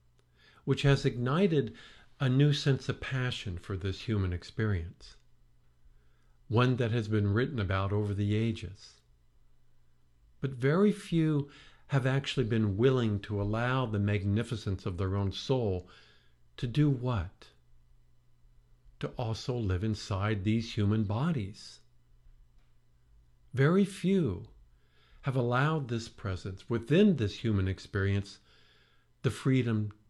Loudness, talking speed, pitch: -31 LUFS, 115 wpm, 105 Hz